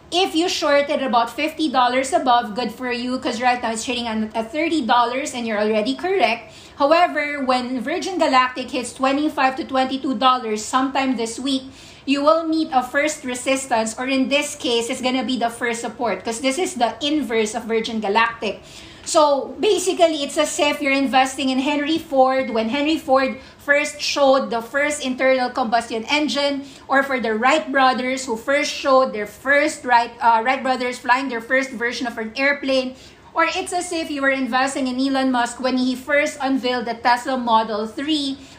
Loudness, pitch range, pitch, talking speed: -20 LUFS, 245-290 Hz, 265 Hz, 175 wpm